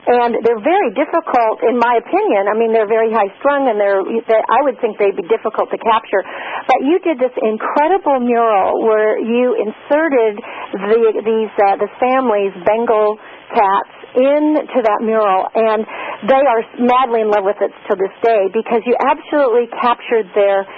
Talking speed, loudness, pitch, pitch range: 170 wpm, -15 LUFS, 230 Hz, 215-260 Hz